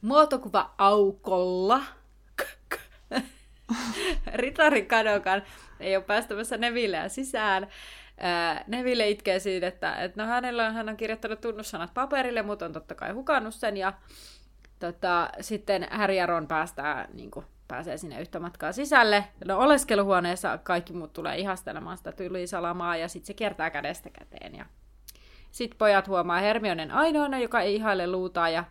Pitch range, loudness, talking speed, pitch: 180-230 Hz, -27 LUFS, 130 wpm, 200 Hz